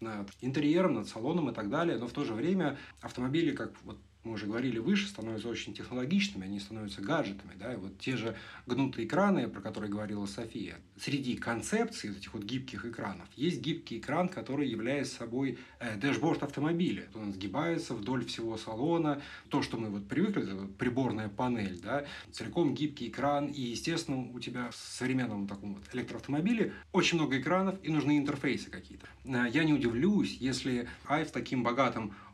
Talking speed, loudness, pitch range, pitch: 170 wpm, -34 LUFS, 110-145 Hz, 125 Hz